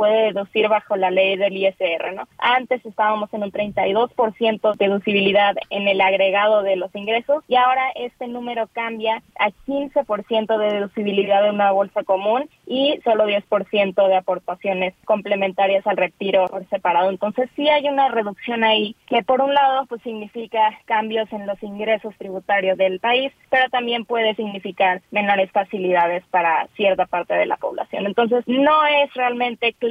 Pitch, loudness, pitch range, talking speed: 210 Hz, -19 LUFS, 195-235 Hz, 160 wpm